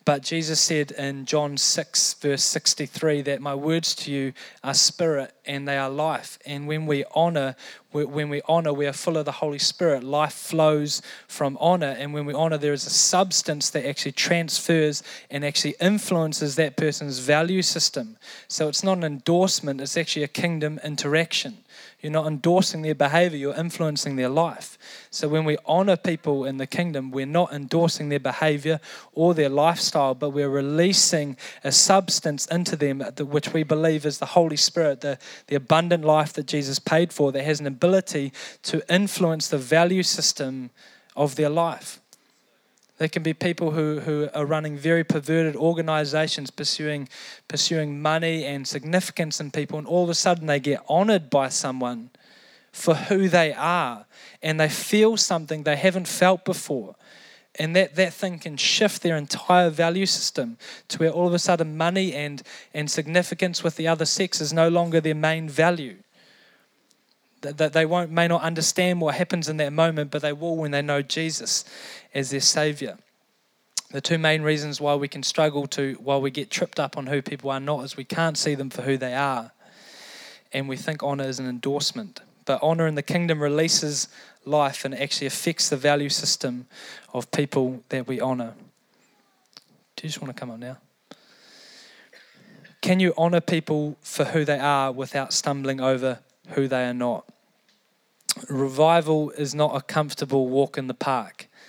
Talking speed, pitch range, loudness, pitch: 175 wpm, 140-170 Hz, -23 LUFS, 155 Hz